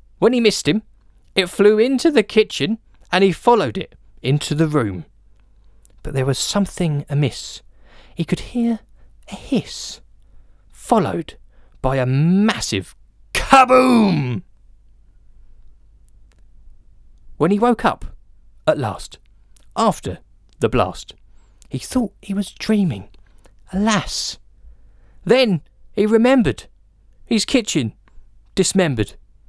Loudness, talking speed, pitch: -18 LUFS, 105 wpm, 145 Hz